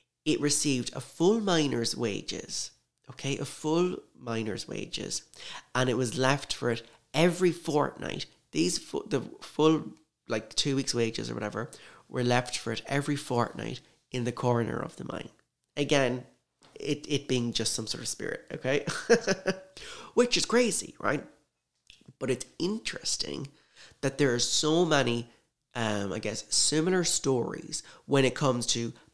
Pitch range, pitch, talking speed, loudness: 120-155 Hz, 135 Hz, 150 wpm, -29 LUFS